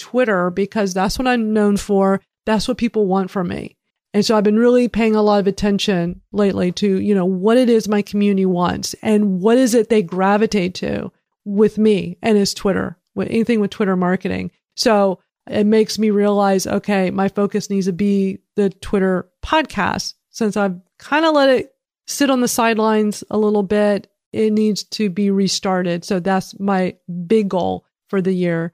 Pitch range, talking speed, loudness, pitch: 190-220 Hz, 190 wpm, -17 LUFS, 205 Hz